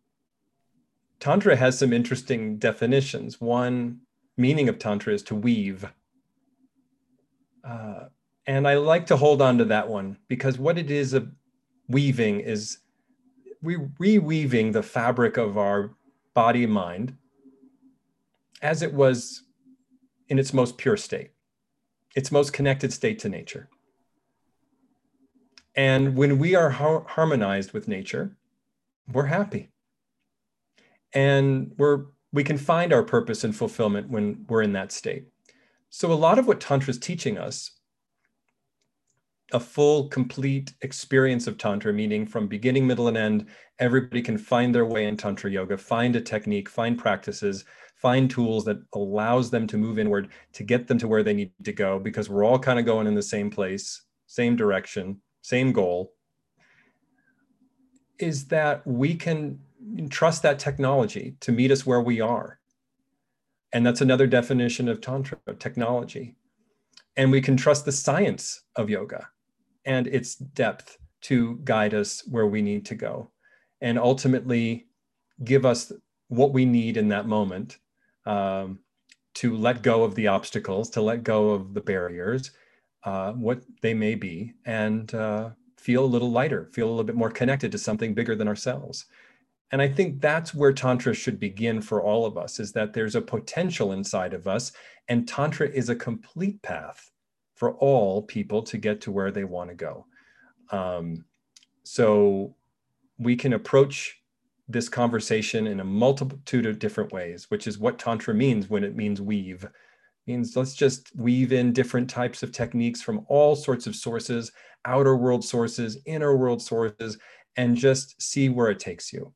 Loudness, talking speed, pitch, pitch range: -24 LUFS, 160 wpm, 125 Hz, 110-145 Hz